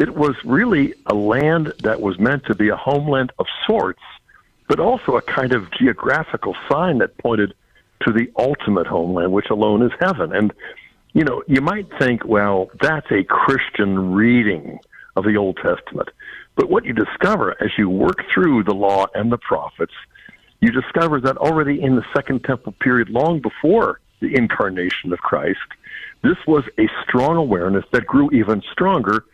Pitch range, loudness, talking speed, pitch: 105-140 Hz, -18 LUFS, 170 wpm, 115 Hz